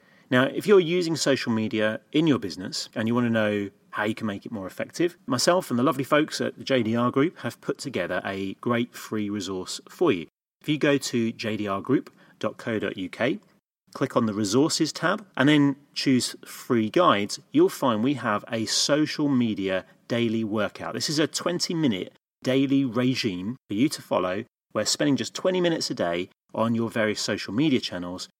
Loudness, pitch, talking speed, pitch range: -25 LUFS, 120 Hz, 180 wpm, 105-145 Hz